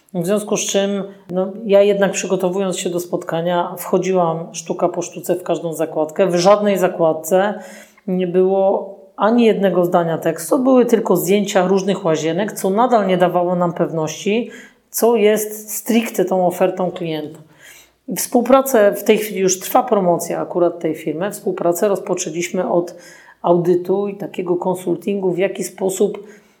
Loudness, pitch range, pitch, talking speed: -17 LUFS, 175-205 Hz, 190 Hz, 145 wpm